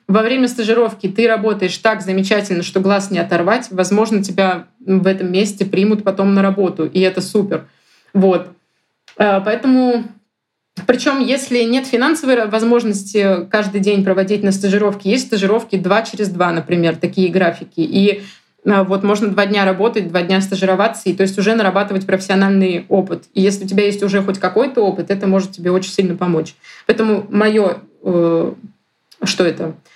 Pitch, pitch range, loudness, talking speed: 200 Hz, 185-215 Hz, -15 LUFS, 160 wpm